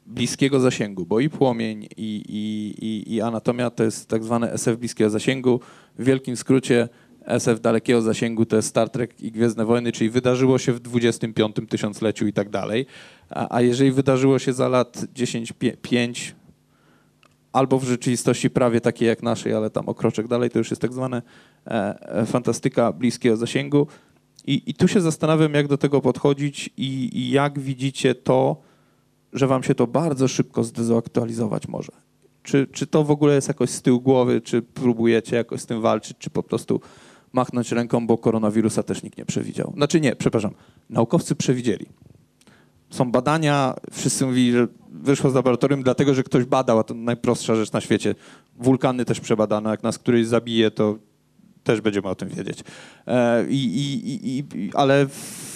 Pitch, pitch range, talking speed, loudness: 120 Hz, 115-135 Hz, 170 wpm, -22 LUFS